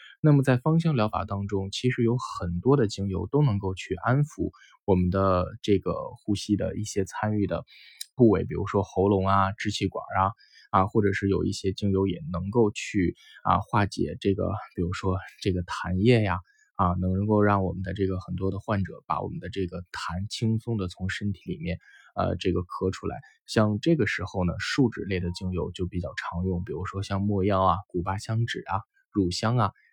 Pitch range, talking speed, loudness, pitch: 95-110 Hz, 285 characters per minute, -27 LUFS, 100 Hz